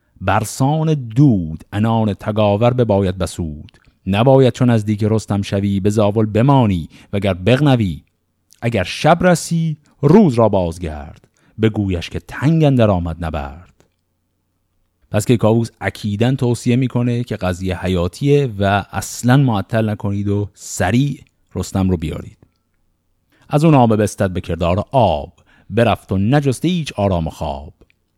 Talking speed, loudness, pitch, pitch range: 130 wpm, -16 LUFS, 105 Hz, 90-120 Hz